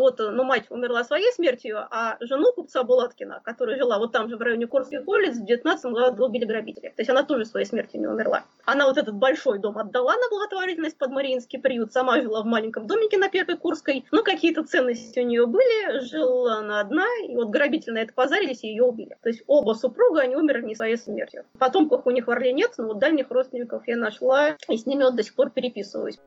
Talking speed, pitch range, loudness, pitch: 225 wpm, 235-310 Hz, -23 LUFS, 260 Hz